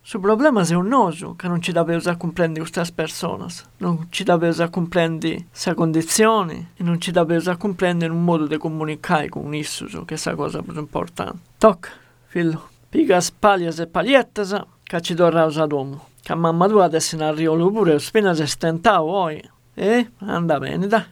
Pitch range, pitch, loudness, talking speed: 160-190 Hz, 170 Hz, -20 LUFS, 215 wpm